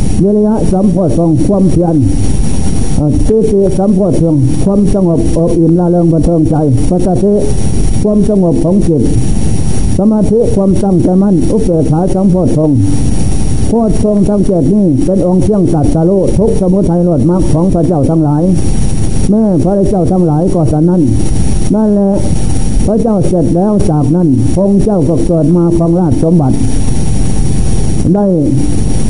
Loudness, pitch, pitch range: -10 LUFS, 175 Hz, 155-195 Hz